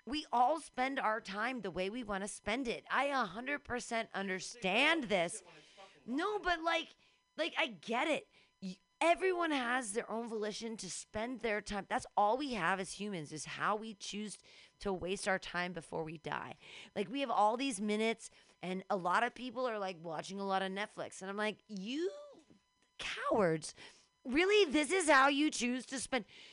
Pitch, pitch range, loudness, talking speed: 220 Hz, 195-265 Hz, -36 LUFS, 180 wpm